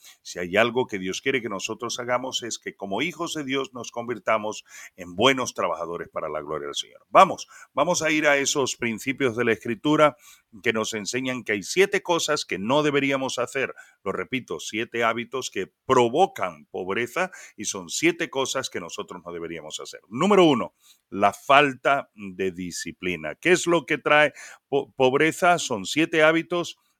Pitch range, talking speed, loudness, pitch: 110-150 Hz, 175 wpm, -24 LUFS, 130 Hz